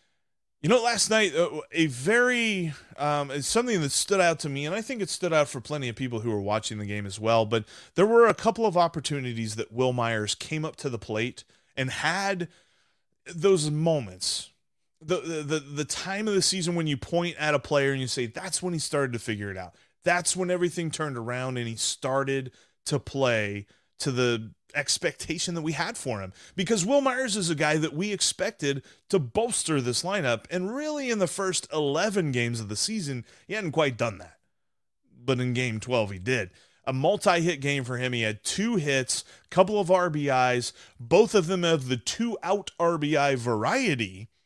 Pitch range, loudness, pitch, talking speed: 125-180 Hz, -26 LUFS, 150 Hz, 200 wpm